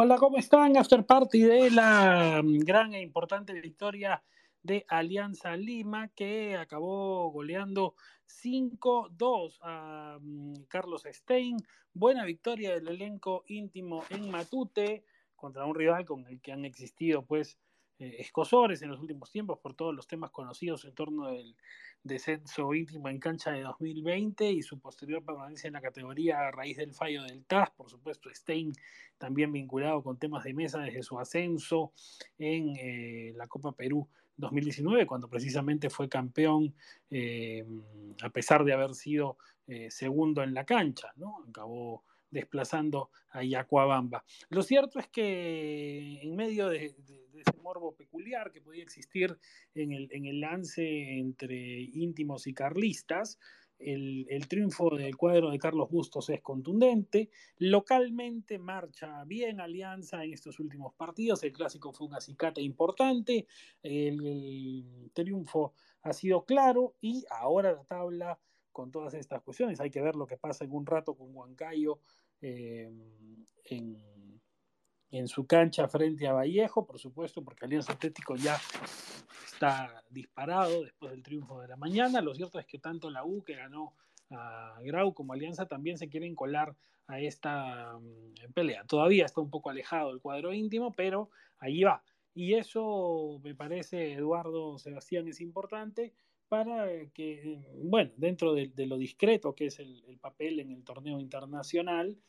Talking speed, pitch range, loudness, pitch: 150 wpm, 140-185 Hz, -32 LUFS, 155 Hz